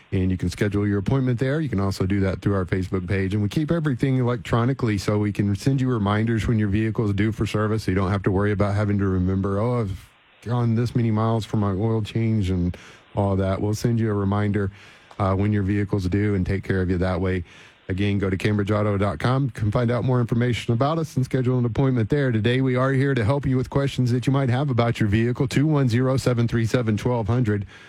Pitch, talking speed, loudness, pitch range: 110 Hz, 250 wpm, -23 LUFS, 100-125 Hz